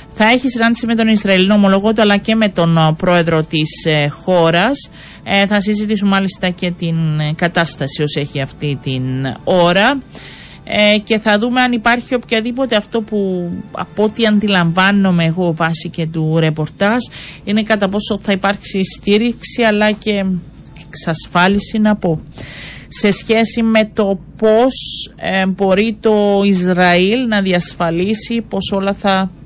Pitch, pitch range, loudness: 195 Hz, 170-215 Hz, -13 LUFS